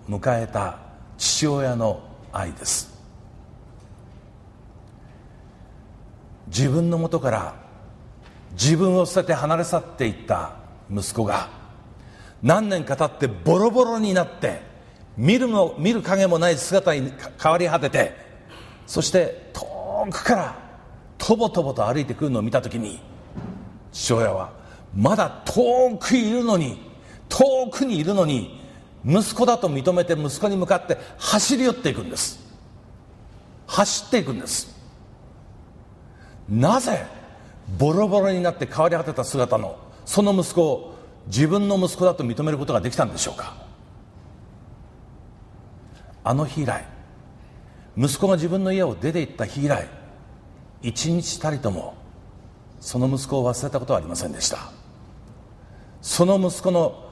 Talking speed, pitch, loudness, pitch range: 245 characters per minute, 140 Hz, -22 LUFS, 110-180 Hz